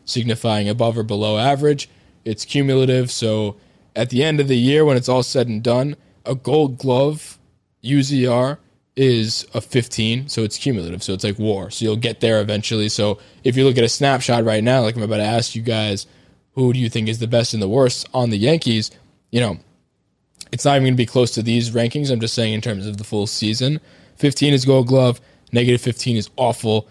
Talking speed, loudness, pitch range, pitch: 215 wpm, -18 LUFS, 110-130 Hz, 120 Hz